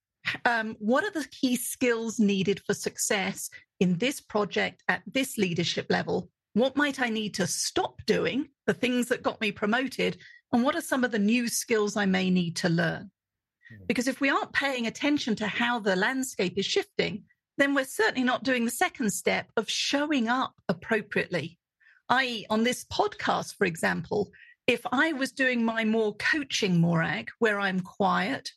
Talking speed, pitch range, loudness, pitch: 175 wpm, 205-265 Hz, -27 LUFS, 235 Hz